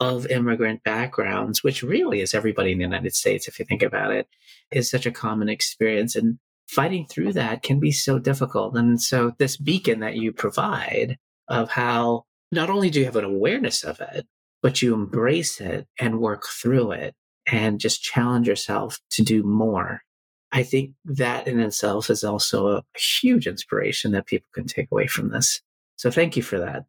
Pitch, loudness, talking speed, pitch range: 120 Hz, -23 LUFS, 185 wpm, 110-135 Hz